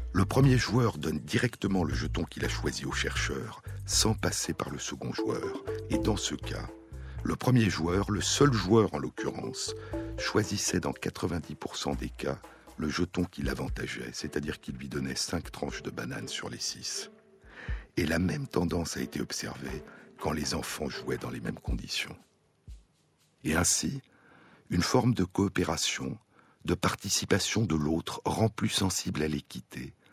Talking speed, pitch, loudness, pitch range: 160 wpm, 95 Hz, -31 LUFS, 80-110 Hz